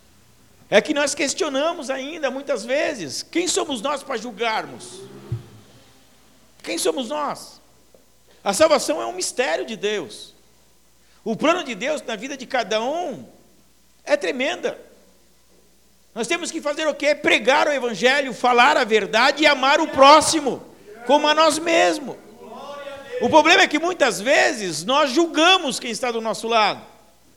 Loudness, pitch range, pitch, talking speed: -19 LUFS, 245-310 Hz, 285 Hz, 145 wpm